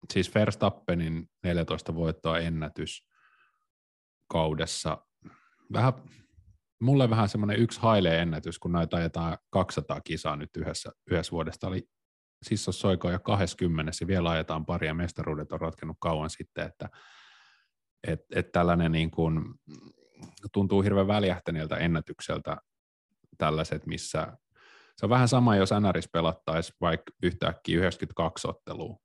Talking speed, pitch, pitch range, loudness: 120 wpm, 85 Hz, 80-100 Hz, -29 LUFS